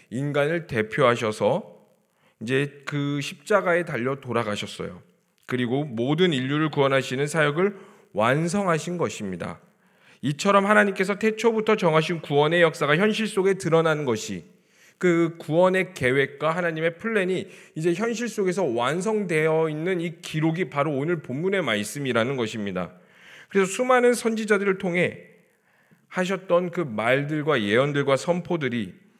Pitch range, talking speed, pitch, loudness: 140-190 Hz, 310 characters per minute, 165 Hz, -24 LUFS